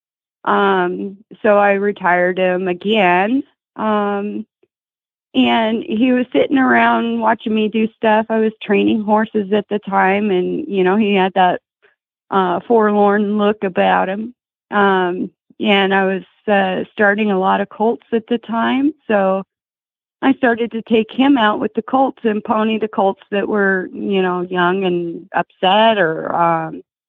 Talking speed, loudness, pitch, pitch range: 155 wpm, -16 LUFS, 210 Hz, 190-225 Hz